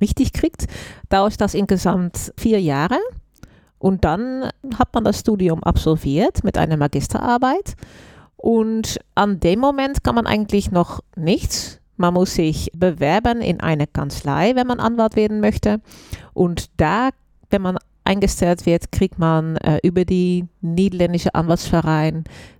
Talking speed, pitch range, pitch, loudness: 135 wpm, 160-215 Hz, 185 Hz, -19 LUFS